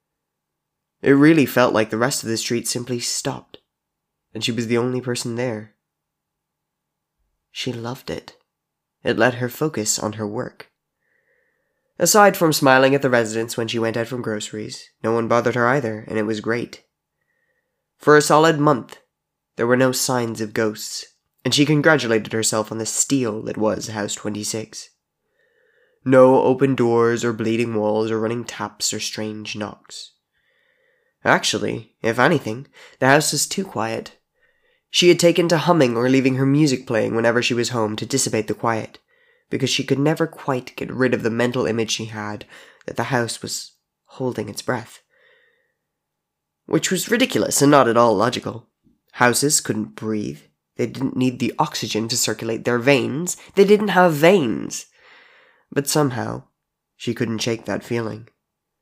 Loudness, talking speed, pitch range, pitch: -19 LUFS, 160 wpm, 110-150 Hz, 120 Hz